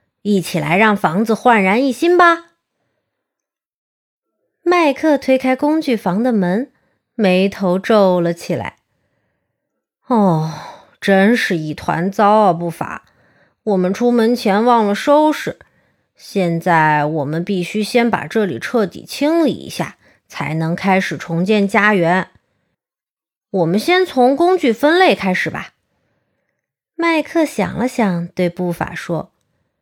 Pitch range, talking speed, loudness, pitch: 180-250 Hz, 175 characters per minute, -15 LUFS, 205 Hz